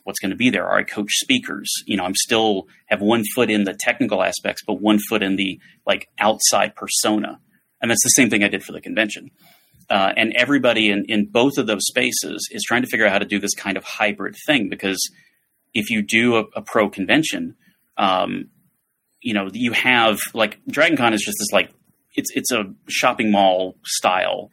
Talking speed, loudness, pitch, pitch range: 210 wpm, -19 LUFS, 105 Hz, 100-115 Hz